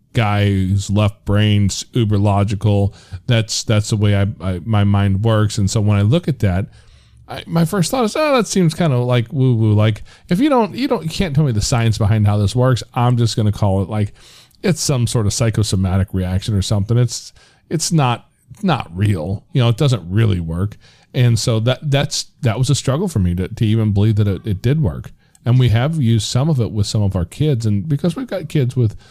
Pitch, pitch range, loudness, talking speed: 115 Hz, 105-140 Hz, -17 LUFS, 235 wpm